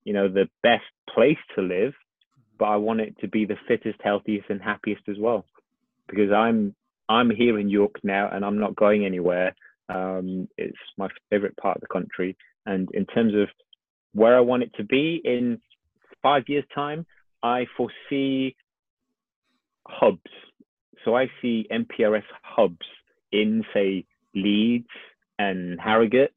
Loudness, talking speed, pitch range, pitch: -24 LUFS, 150 wpm, 100-120 Hz, 110 Hz